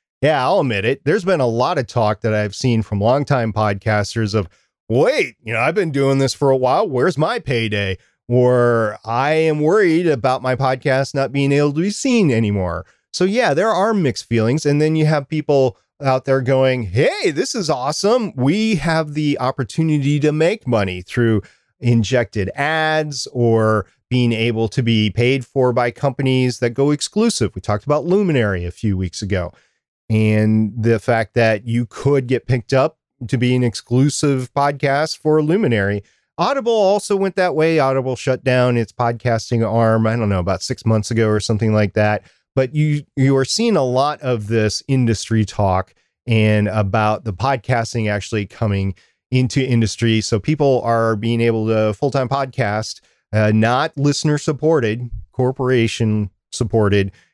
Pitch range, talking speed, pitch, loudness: 110-140 Hz, 170 wpm, 125 Hz, -18 LUFS